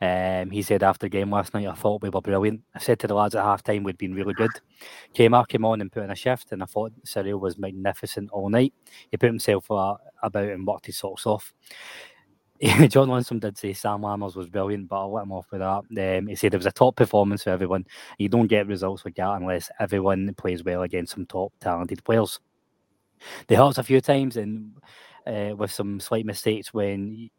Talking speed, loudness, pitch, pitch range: 225 wpm, -24 LUFS, 100 Hz, 95-110 Hz